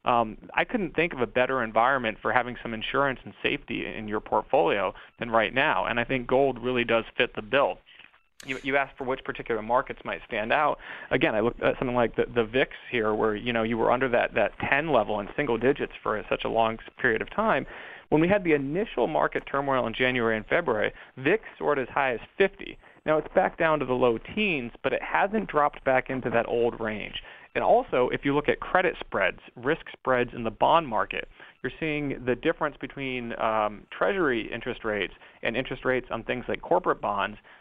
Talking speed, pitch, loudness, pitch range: 215 wpm, 130 Hz, -26 LUFS, 115-145 Hz